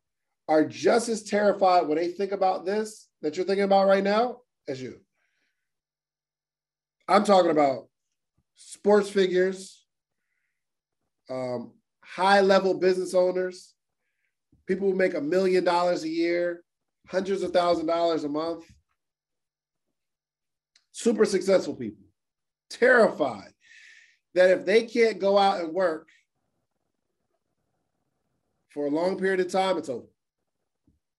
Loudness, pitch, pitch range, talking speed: -24 LUFS, 185 Hz, 175-200 Hz, 115 wpm